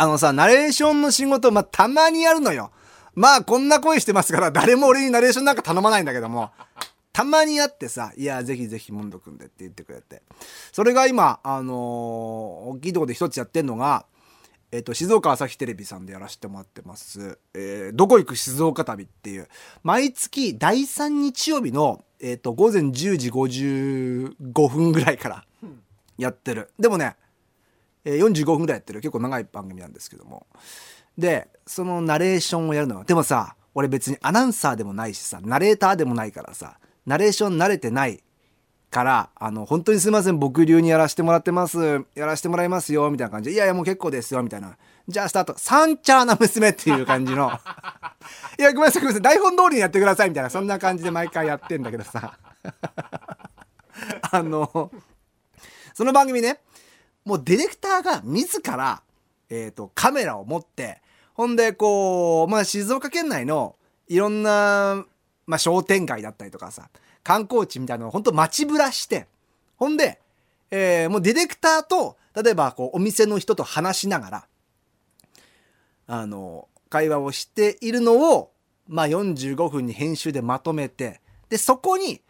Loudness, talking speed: -20 LUFS, 360 characters per minute